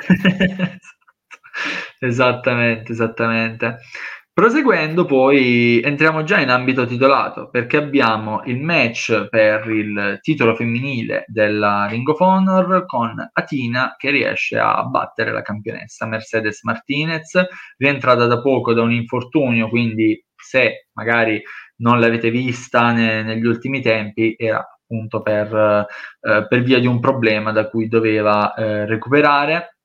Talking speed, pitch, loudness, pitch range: 125 wpm, 120 Hz, -17 LUFS, 110-135 Hz